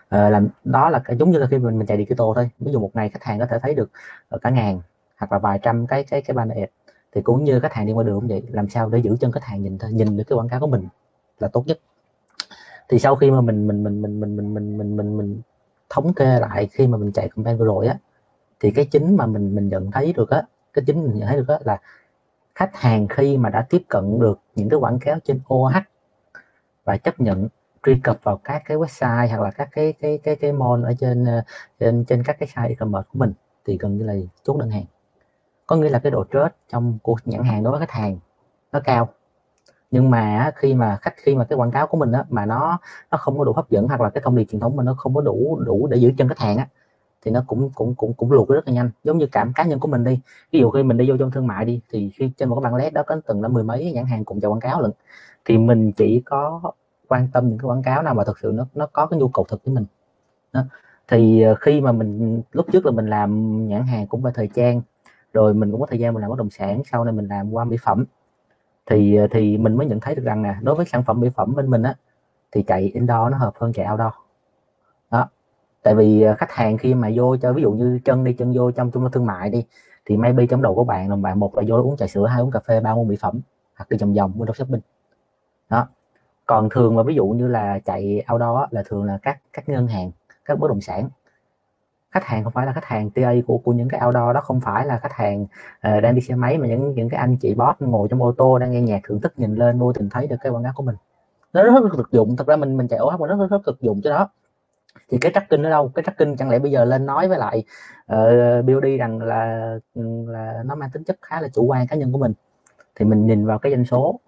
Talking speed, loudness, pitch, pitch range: 275 wpm, -20 LUFS, 120 Hz, 110-135 Hz